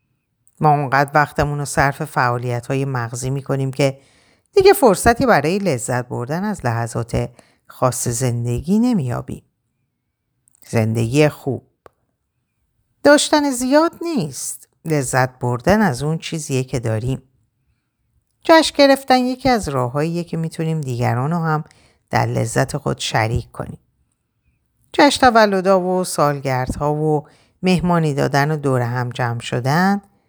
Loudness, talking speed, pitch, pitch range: -18 LUFS, 120 wpm, 145 Hz, 125-185 Hz